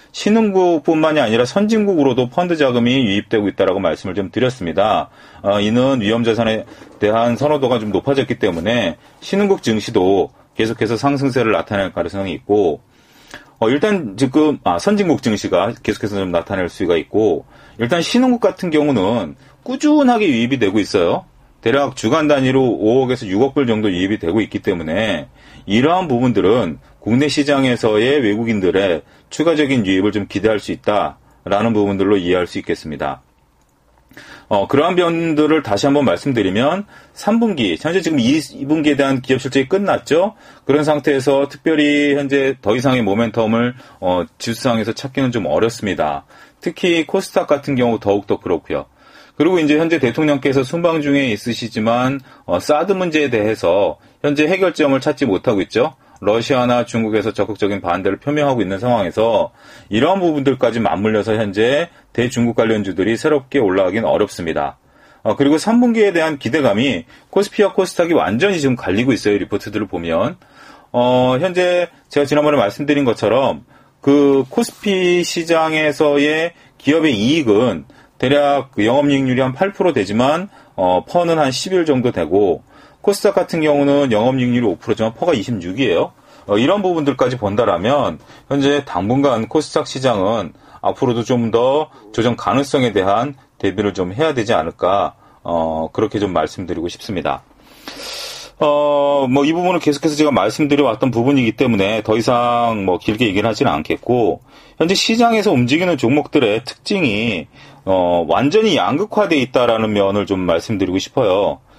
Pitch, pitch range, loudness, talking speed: 135 Hz, 110-155 Hz, -16 LUFS, 340 characters per minute